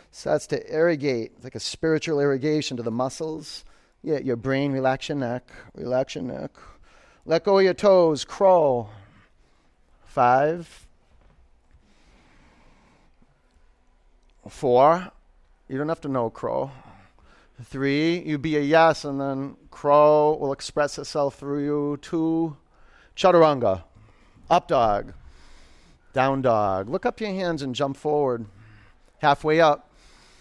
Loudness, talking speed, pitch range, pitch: -23 LUFS, 125 wpm, 100-155 Hz, 135 Hz